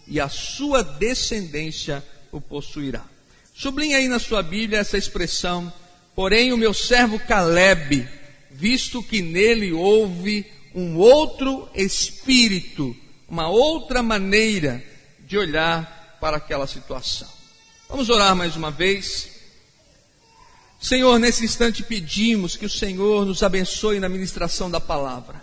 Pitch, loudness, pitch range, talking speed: 195 Hz, -20 LUFS, 165-225 Hz, 120 wpm